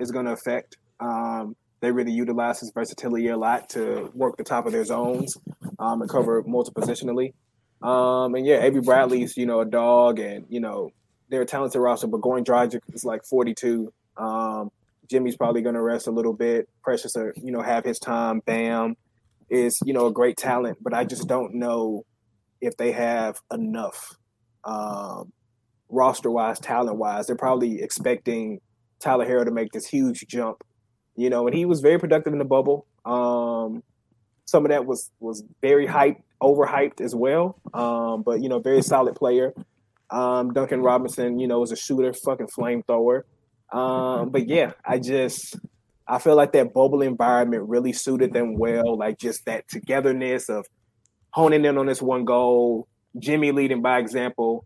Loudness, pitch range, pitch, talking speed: -23 LUFS, 115-130 Hz, 120 Hz, 175 wpm